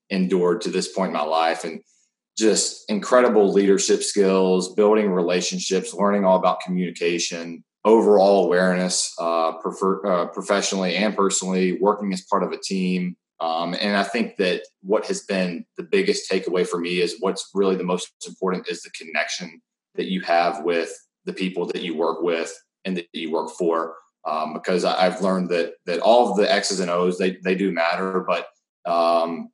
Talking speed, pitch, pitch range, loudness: 175 wpm, 90 Hz, 85-95 Hz, -21 LUFS